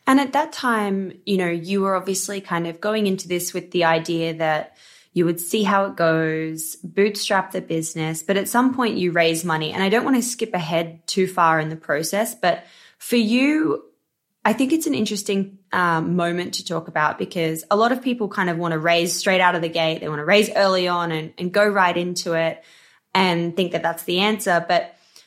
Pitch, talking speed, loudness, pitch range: 180 Hz, 220 wpm, -21 LUFS, 165-205 Hz